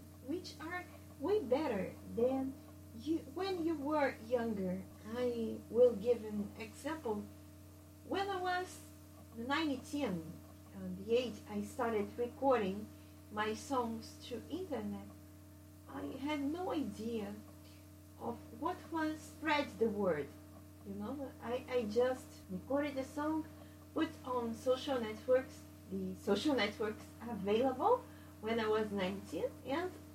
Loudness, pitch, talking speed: -38 LUFS, 235 Hz, 115 wpm